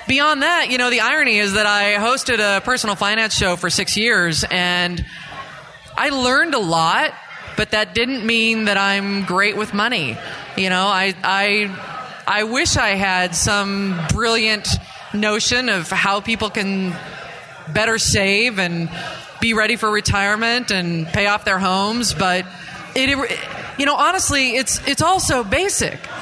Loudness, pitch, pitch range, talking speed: -17 LUFS, 210 Hz, 190-235 Hz, 155 wpm